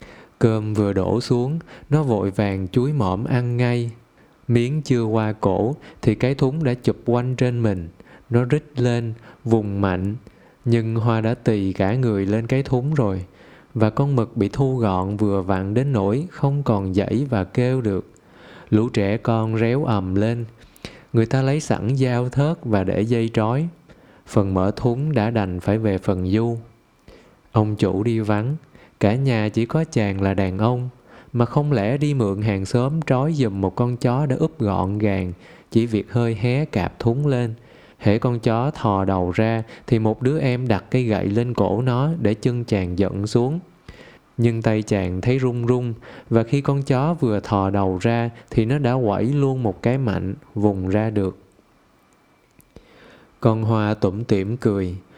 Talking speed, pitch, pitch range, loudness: 180 wpm, 115 Hz, 100-125 Hz, -21 LUFS